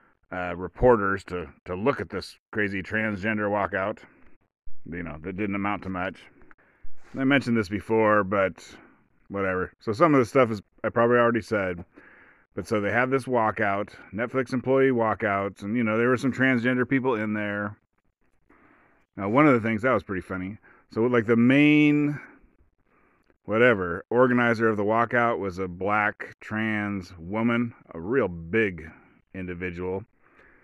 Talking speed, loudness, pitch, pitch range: 155 wpm, -25 LUFS, 110 Hz, 95-120 Hz